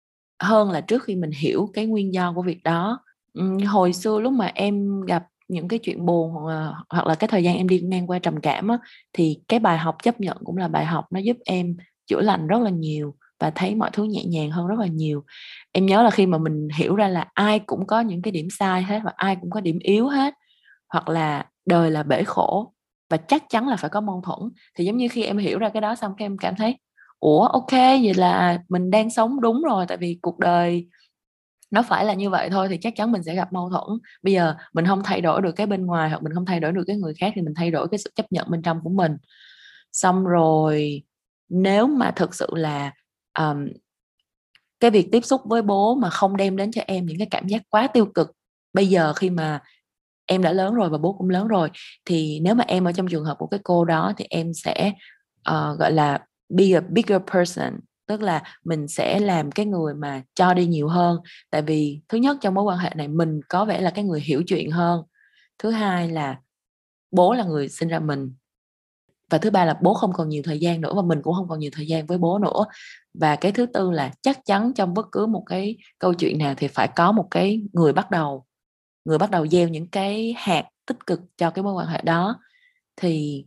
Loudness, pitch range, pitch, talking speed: -22 LUFS, 165-210 Hz, 180 Hz, 240 wpm